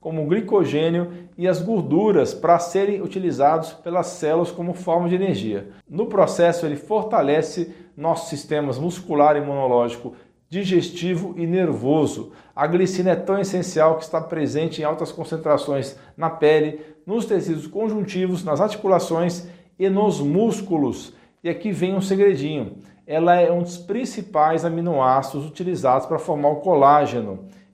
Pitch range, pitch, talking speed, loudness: 150-185 Hz, 170 Hz, 135 wpm, -21 LUFS